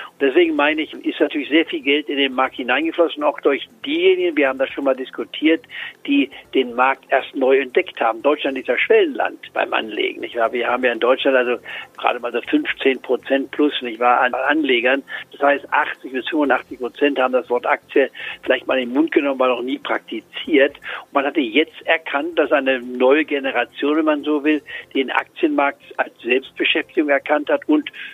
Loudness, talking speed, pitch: -19 LUFS, 195 wpm, 145 Hz